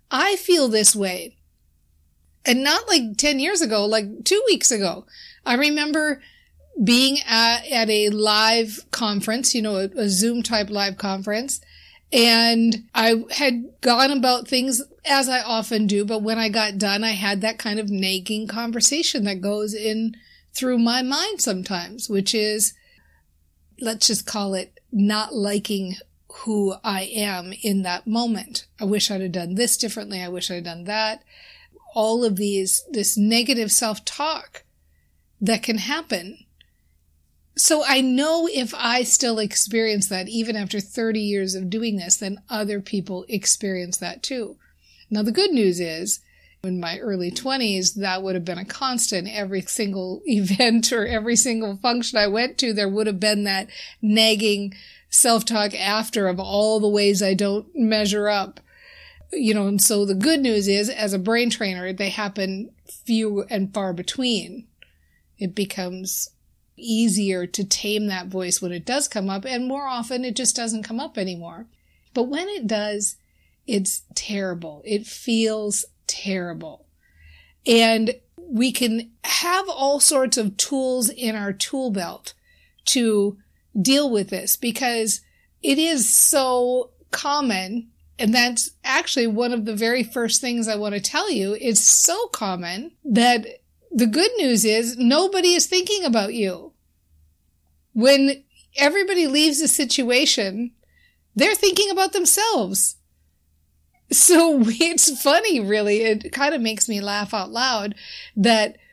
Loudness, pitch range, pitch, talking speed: -20 LUFS, 195-250 Hz, 220 Hz, 155 wpm